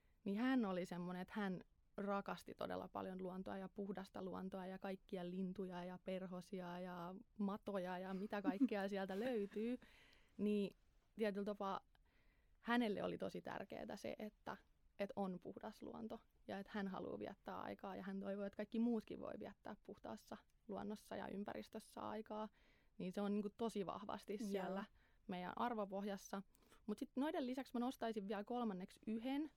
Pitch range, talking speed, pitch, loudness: 190-220 Hz, 150 wpm, 200 Hz, -47 LUFS